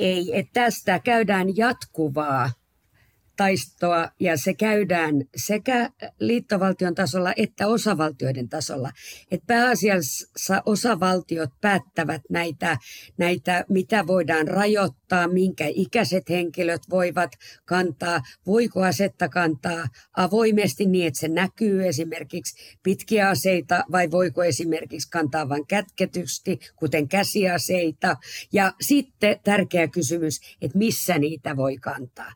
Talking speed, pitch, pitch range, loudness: 105 wpm, 180 Hz, 160-195 Hz, -23 LUFS